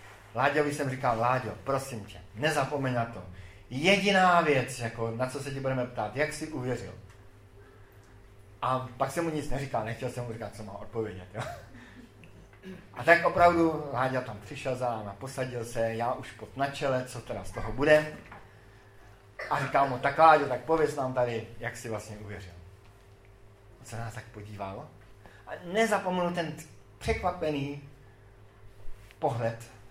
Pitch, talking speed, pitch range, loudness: 115 Hz, 160 wpm, 100-140 Hz, -29 LUFS